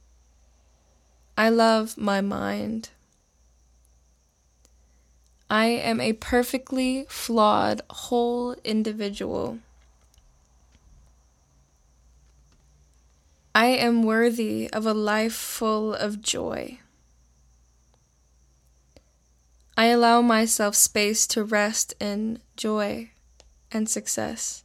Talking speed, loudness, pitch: 75 wpm, -23 LUFS, 85 Hz